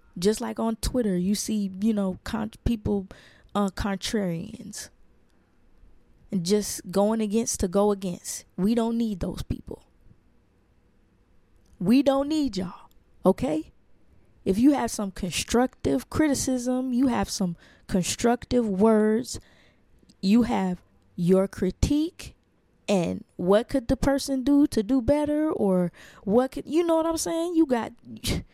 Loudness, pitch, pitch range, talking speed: -25 LUFS, 215 Hz, 190-255 Hz, 130 wpm